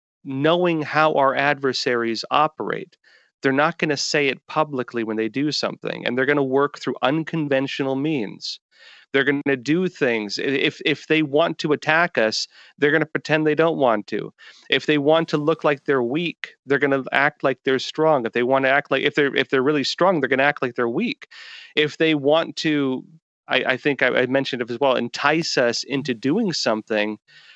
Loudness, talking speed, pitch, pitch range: -21 LUFS, 210 wpm, 145 Hz, 130-155 Hz